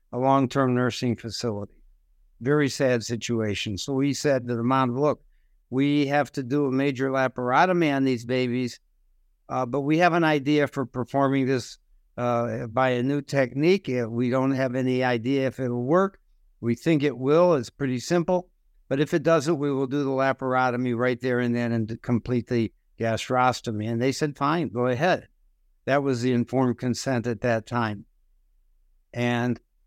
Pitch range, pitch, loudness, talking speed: 120-140 Hz, 125 Hz, -25 LUFS, 175 wpm